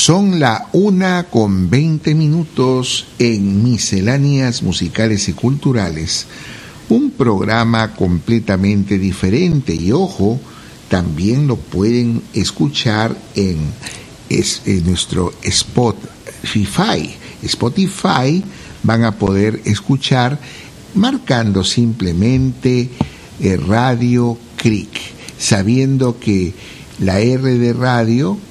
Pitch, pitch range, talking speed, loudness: 120 Hz, 100-135 Hz, 85 wpm, -15 LUFS